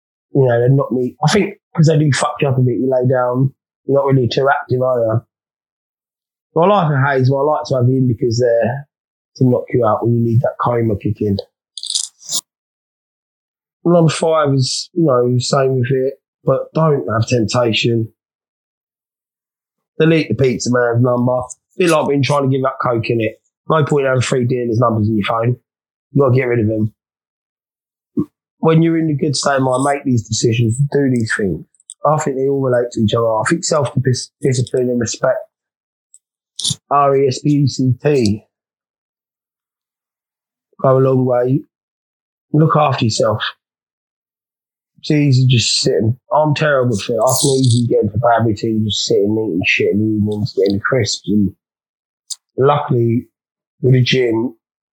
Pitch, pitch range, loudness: 130 Hz, 115-140 Hz, -15 LUFS